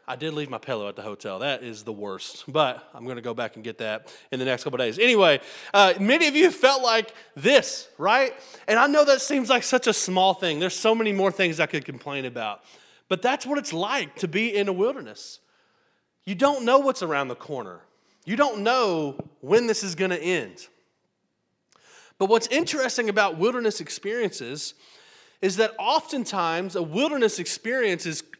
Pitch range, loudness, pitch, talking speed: 160-265 Hz, -23 LUFS, 205 Hz, 200 wpm